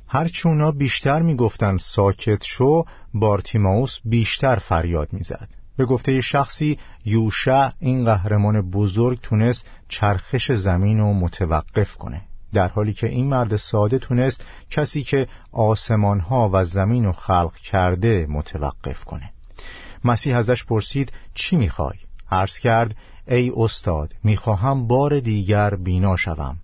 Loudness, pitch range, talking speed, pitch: -20 LUFS, 95-125 Hz, 120 wpm, 110 Hz